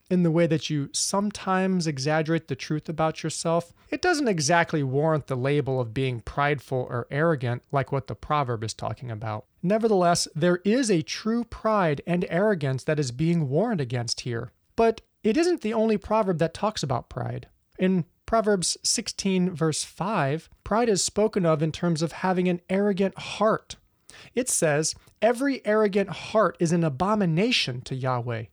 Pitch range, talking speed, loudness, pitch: 140-205 Hz, 165 wpm, -25 LUFS, 165 Hz